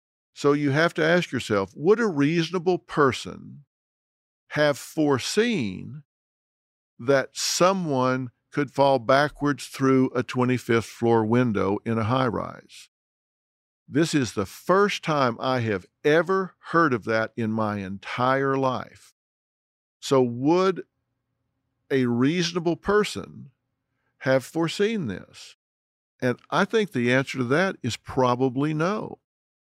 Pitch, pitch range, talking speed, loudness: 135 Hz, 120-160 Hz, 120 wpm, -24 LUFS